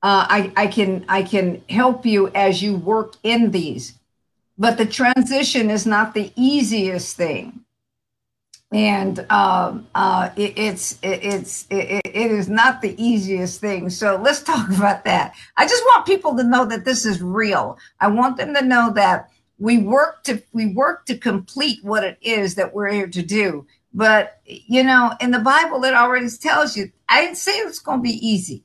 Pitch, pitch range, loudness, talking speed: 215 Hz, 195-250 Hz, -18 LUFS, 185 wpm